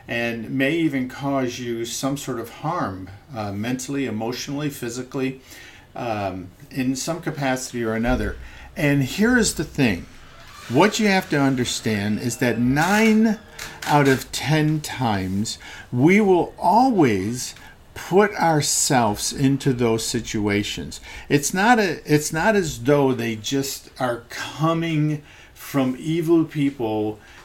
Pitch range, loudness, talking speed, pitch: 115-155 Hz, -21 LUFS, 125 wpm, 135 Hz